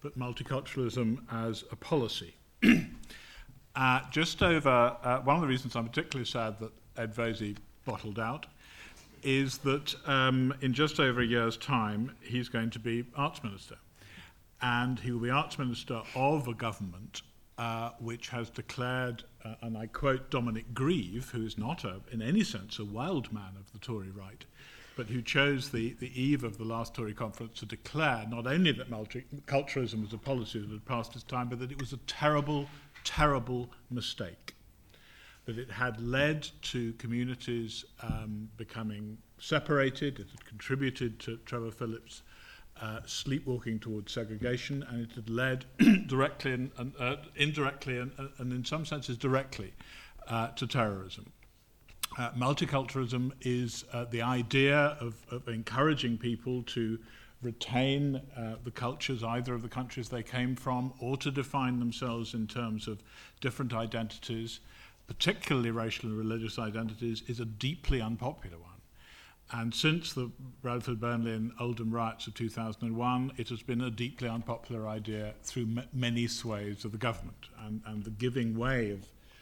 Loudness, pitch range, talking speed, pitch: -33 LUFS, 115-130 Hz, 160 wpm, 120 Hz